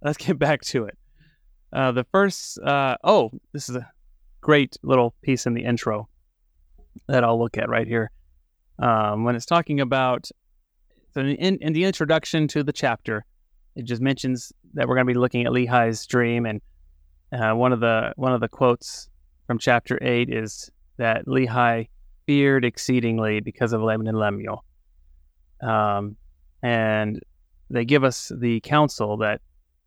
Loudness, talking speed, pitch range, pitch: -22 LUFS, 165 wpm, 105-130 Hz, 120 Hz